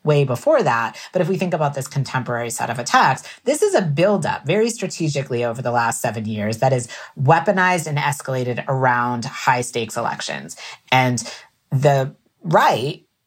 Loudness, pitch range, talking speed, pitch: -20 LUFS, 120-150 Hz, 165 wpm, 130 Hz